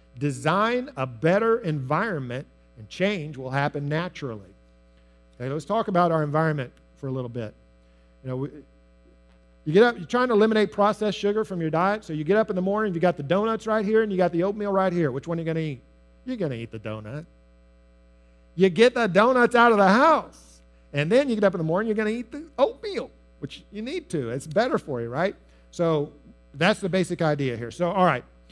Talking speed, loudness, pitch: 225 wpm, -24 LUFS, 160 Hz